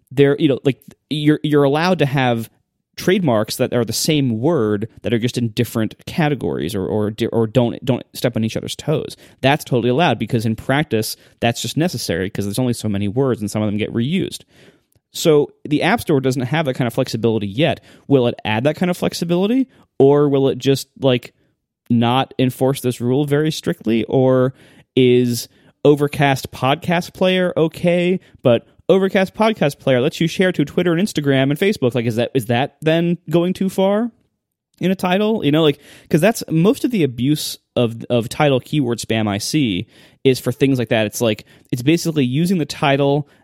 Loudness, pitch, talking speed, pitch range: -18 LUFS, 135 Hz, 195 wpm, 120-160 Hz